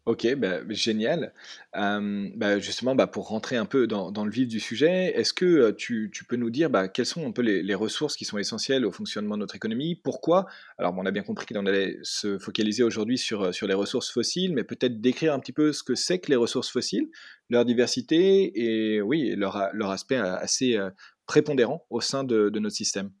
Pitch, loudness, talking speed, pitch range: 120 Hz, -26 LUFS, 220 wpm, 105-150 Hz